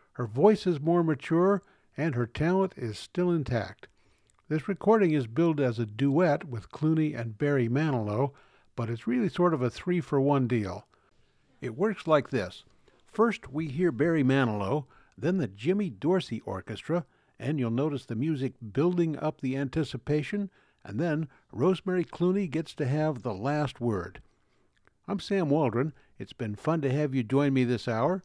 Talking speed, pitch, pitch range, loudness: 165 wpm, 145 Hz, 125-170 Hz, -29 LUFS